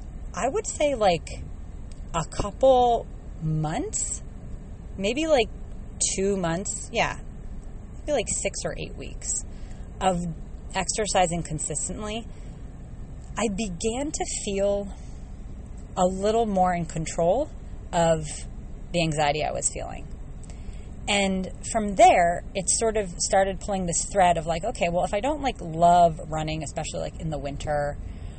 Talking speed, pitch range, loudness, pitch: 130 wpm, 160-215 Hz, -25 LUFS, 180 Hz